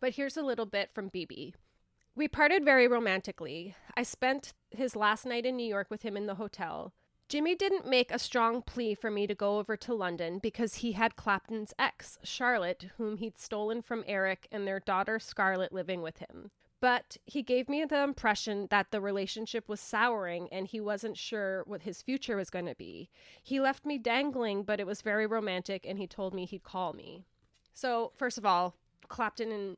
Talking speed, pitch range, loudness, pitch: 195 wpm, 195-245 Hz, -33 LUFS, 215 Hz